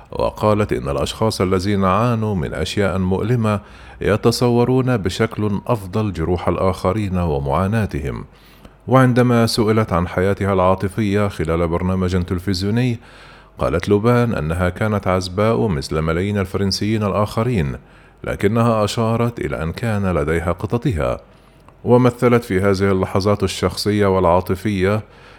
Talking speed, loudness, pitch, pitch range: 105 wpm, -18 LUFS, 100 Hz, 95-115 Hz